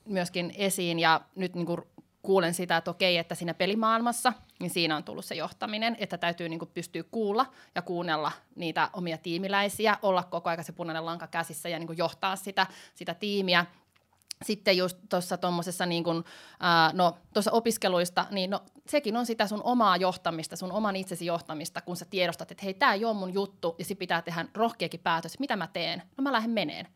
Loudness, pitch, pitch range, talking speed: -29 LUFS, 180 Hz, 170-200 Hz, 185 wpm